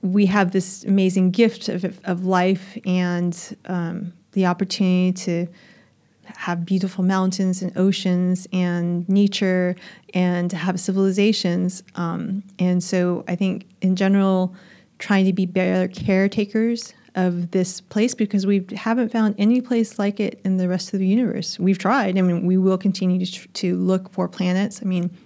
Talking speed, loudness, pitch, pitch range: 160 wpm, -21 LUFS, 190 Hz, 180-200 Hz